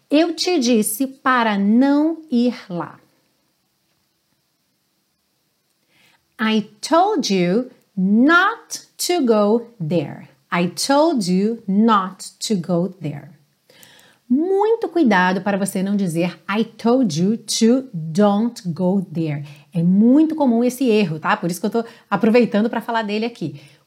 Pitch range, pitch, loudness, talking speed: 185-250 Hz, 220 Hz, -18 LUFS, 125 wpm